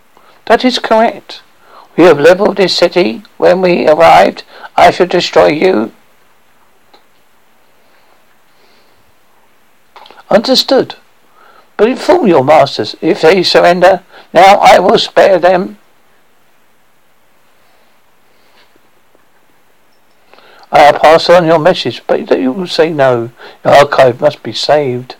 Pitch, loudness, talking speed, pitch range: 180 Hz, -8 LUFS, 100 wpm, 150-200 Hz